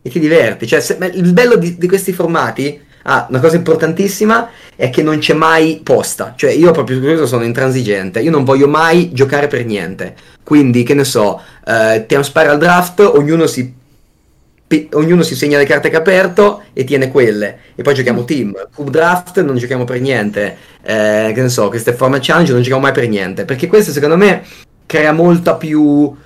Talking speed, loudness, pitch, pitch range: 195 wpm, -11 LUFS, 145 Hz, 125-165 Hz